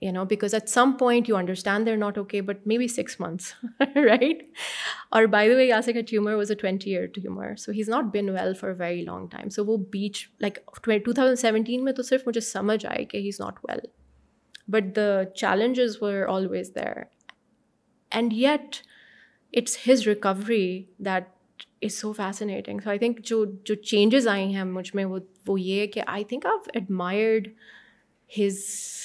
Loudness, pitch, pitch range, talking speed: -25 LUFS, 210 Hz, 195-230 Hz, 185 wpm